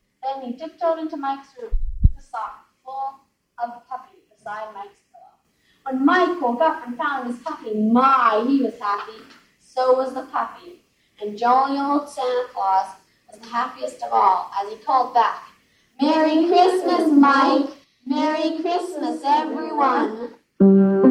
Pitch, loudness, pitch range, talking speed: 270 Hz, -20 LUFS, 235-315 Hz, 150 wpm